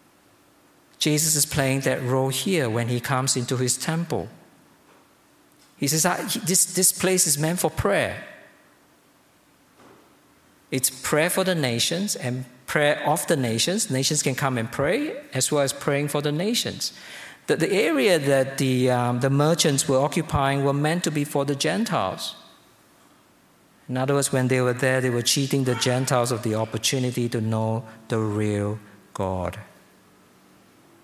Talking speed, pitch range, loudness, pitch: 155 wpm, 120-150 Hz, -23 LUFS, 135 Hz